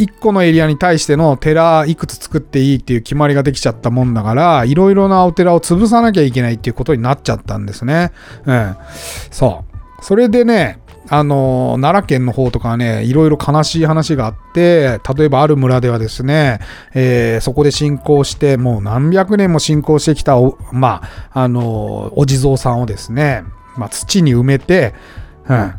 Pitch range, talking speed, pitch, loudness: 115-155 Hz, 365 characters per minute, 135 Hz, -13 LUFS